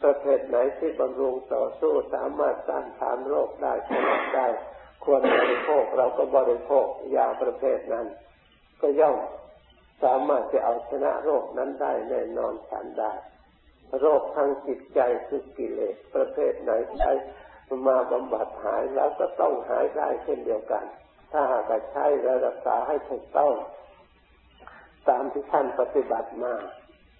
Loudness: -26 LUFS